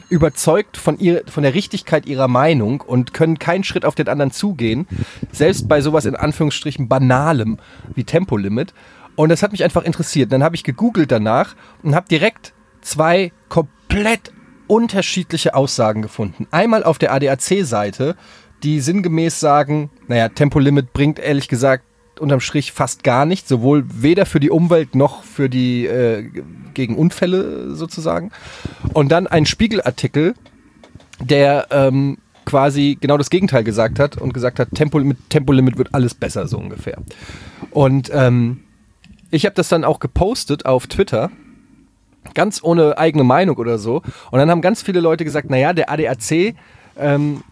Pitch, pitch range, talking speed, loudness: 150 Hz, 130-170 Hz, 155 wpm, -16 LUFS